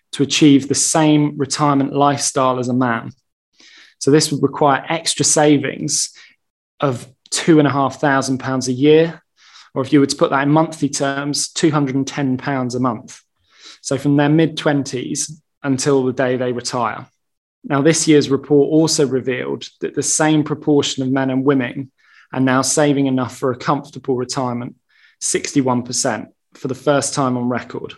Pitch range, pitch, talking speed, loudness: 130-150 Hz, 140 Hz, 150 wpm, -17 LUFS